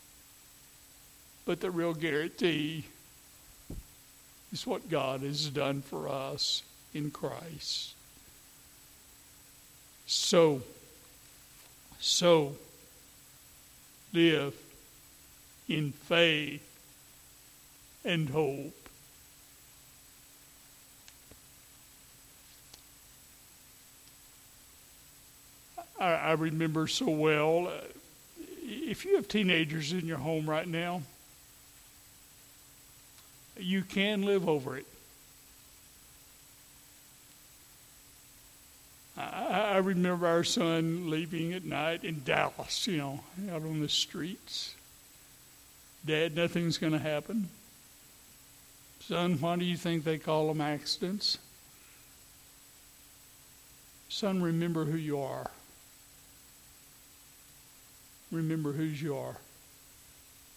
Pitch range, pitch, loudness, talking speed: 150-175 Hz, 160 Hz, -32 LUFS, 80 wpm